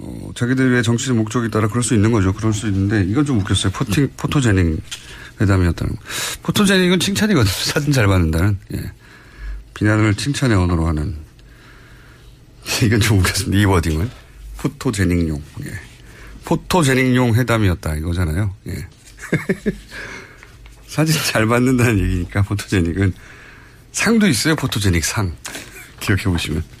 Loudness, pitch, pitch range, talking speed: -18 LUFS, 110 Hz, 95-125 Hz, 315 characters per minute